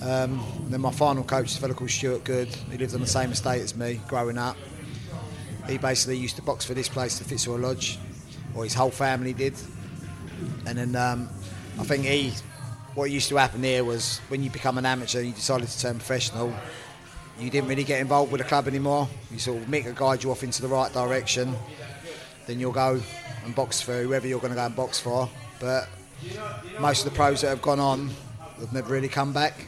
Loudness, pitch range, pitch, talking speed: -27 LUFS, 120-135 Hz, 130 Hz, 220 wpm